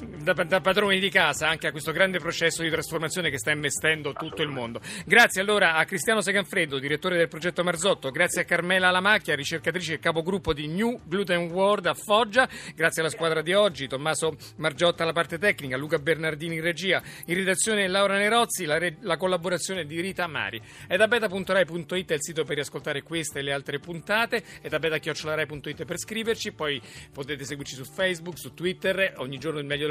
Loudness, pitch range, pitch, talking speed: -25 LUFS, 155-190 Hz, 170 Hz, 185 wpm